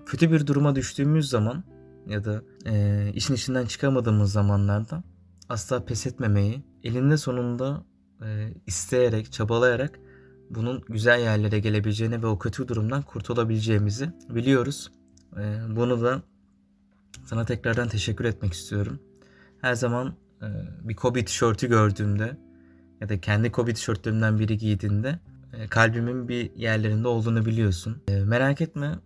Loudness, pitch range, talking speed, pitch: -25 LUFS, 105-125 Hz, 125 wpm, 110 Hz